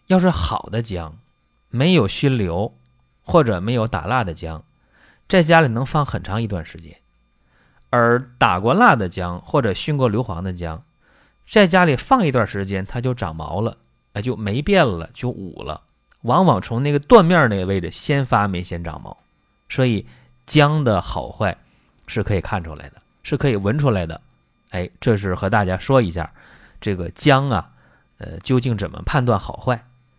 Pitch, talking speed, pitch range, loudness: 105 Hz, 245 characters per minute, 85-130 Hz, -19 LUFS